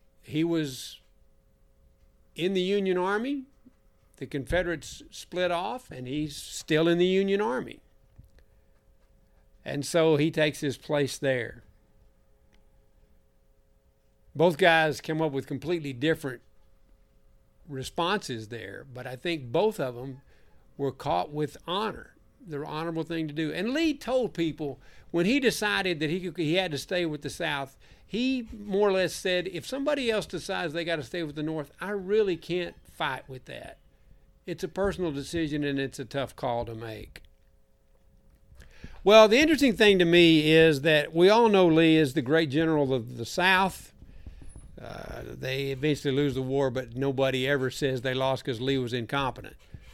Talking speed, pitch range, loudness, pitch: 160 wpm, 130-180 Hz, -26 LUFS, 150 Hz